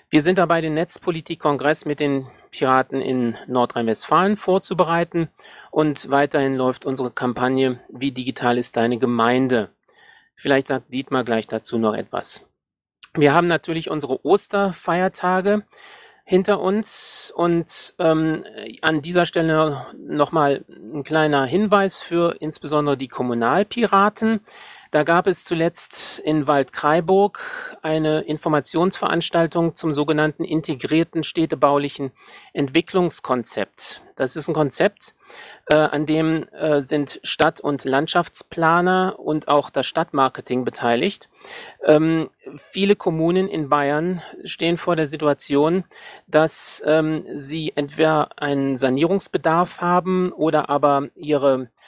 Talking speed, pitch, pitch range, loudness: 110 wpm, 155 Hz, 140-175 Hz, -20 LUFS